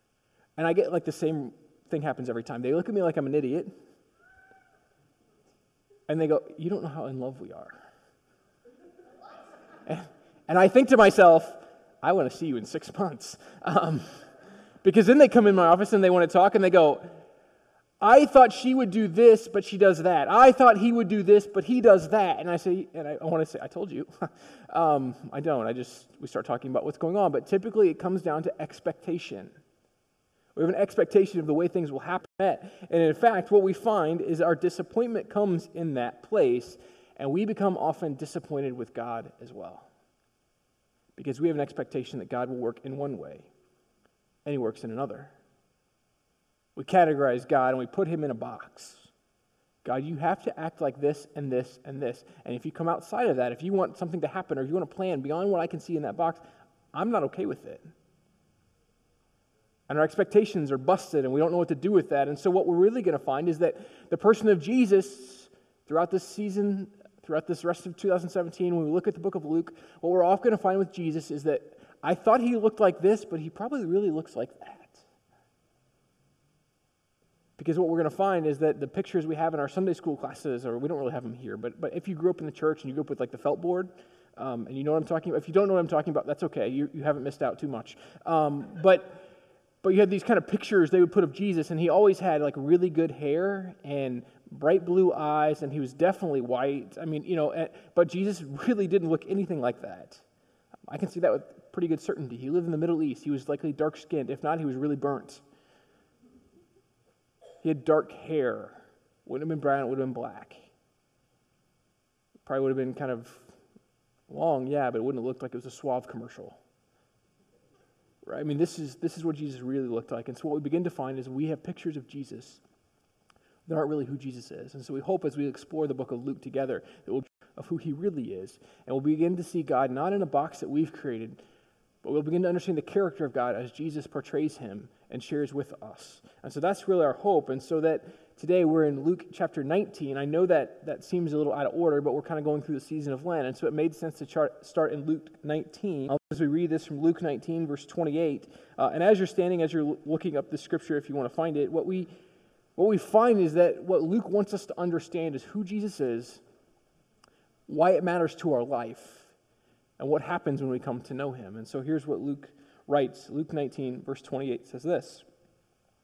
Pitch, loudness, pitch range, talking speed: 160 Hz, -27 LUFS, 145-185 Hz, 230 wpm